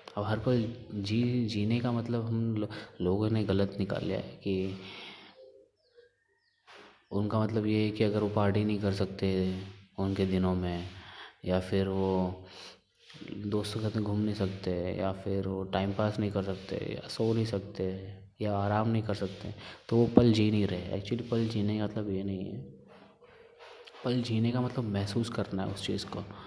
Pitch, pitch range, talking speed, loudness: 105 Hz, 95-115 Hz, 180 wpm, -31 LUFS